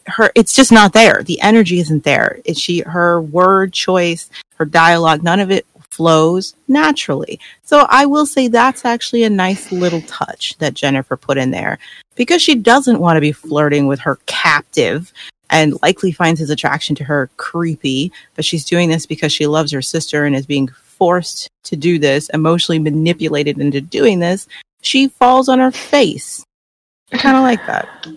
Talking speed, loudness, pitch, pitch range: 180 wpm, -13 LUFS, 170 Hz, 150-220 Hz